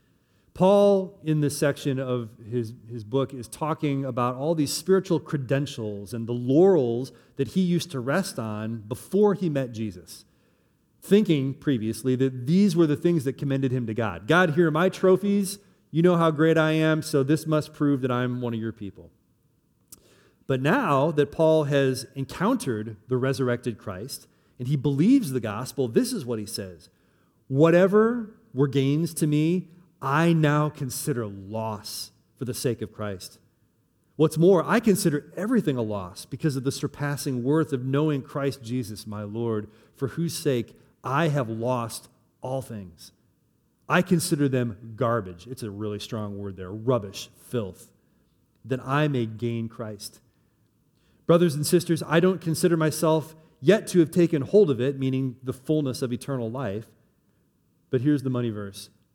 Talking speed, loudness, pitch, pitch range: 165 wpm, -25 LUFS, 135 Hz, 115-160 Hz